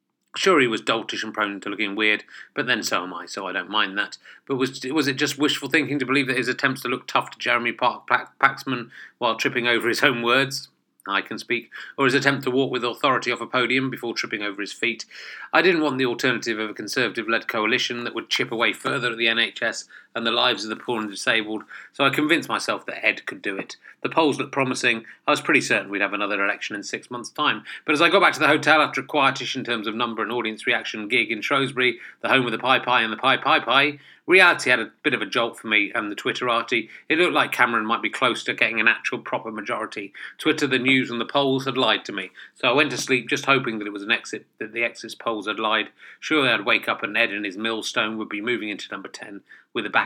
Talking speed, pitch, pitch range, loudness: 260 wpm, 125 Hz, 115-135 Hz, -22 LUFS